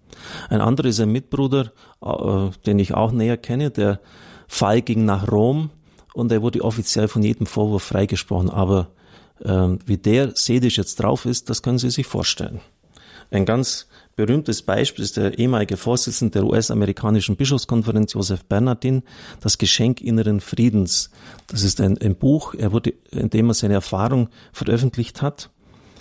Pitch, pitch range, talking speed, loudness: 110 Hz, 100-120 Hz, 155 wpm, -20 LUFS